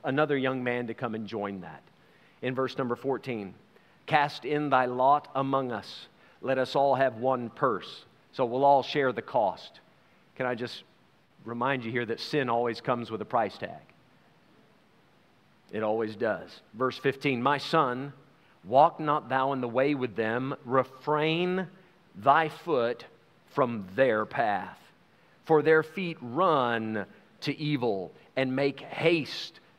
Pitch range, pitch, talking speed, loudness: 120-150 Hz, 130 Hz, 150 wpm, -28 LUFS